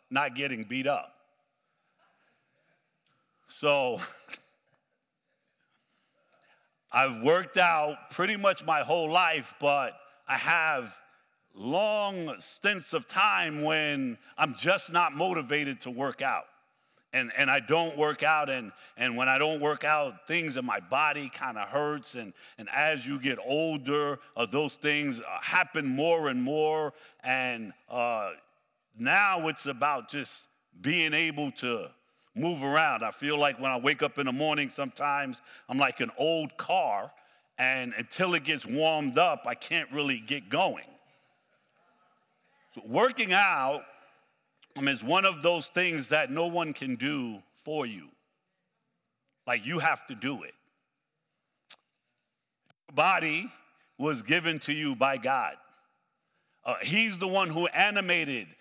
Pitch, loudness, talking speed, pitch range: 150 Hz, -28 LUFS, 140 wpm, 140-170 Hz